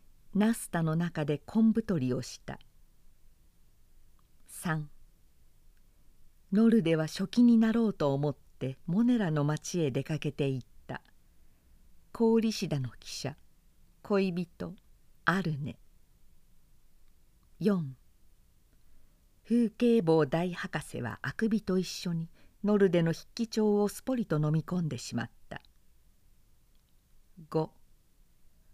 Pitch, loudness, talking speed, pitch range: 160 Hz, -30 LUFS, 180 characters per minute, 135-205 Hz